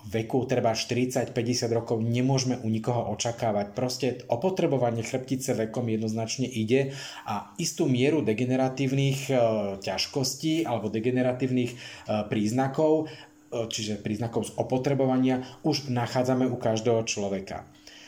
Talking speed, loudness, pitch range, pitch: 115 wpm, -27 LUFS, 115-135 Hz, 125 Hz